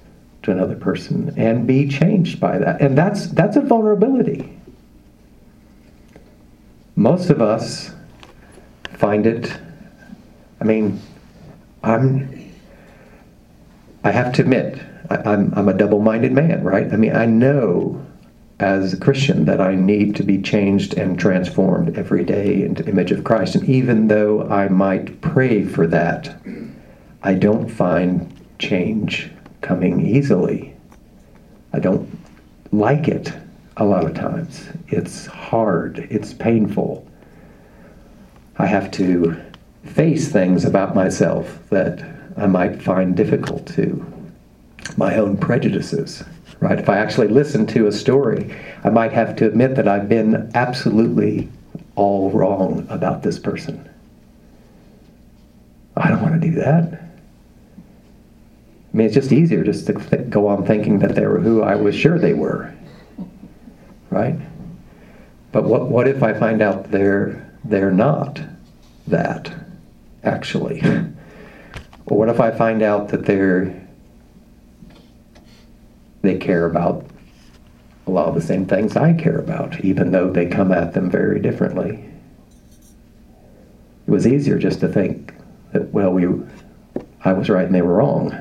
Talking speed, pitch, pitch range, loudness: 135 wpm, 105 Hz, 90-135 Hz, -18 LUFS